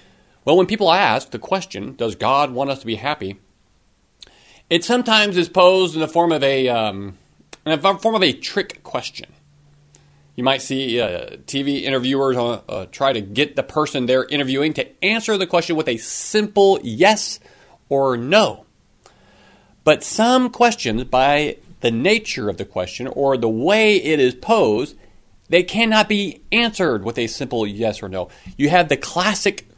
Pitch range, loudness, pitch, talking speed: 125-185 Hz, -18 LUFS, 145 Hz, 165 wpm